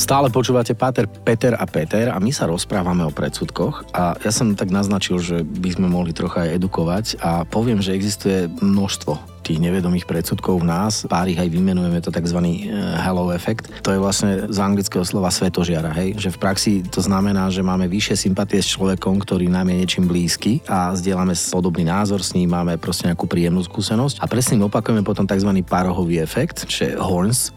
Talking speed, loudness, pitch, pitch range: 190 wpm, -19 LUFS, 95 Hz, 90-100 Hz